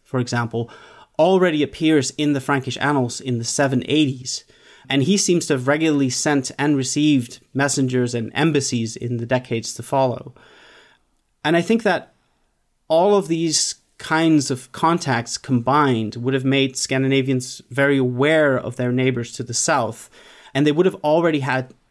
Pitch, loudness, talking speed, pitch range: 135 Hz, -20 LUFS, 155 wpm, 125-150 Hz